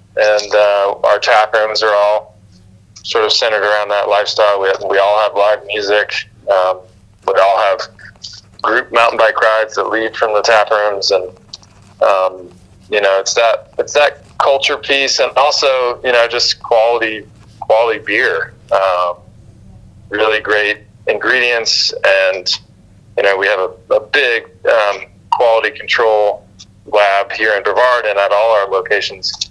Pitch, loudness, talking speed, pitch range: 105 Hz, -13 LUFS, 155 wpm, 100-110 Hz